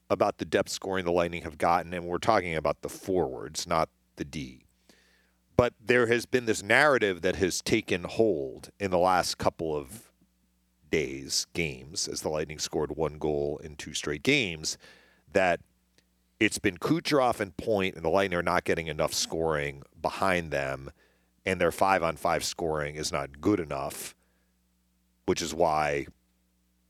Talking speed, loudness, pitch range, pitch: 160 wpm, -28 LUFS, 60-90 Hz, 75 Hz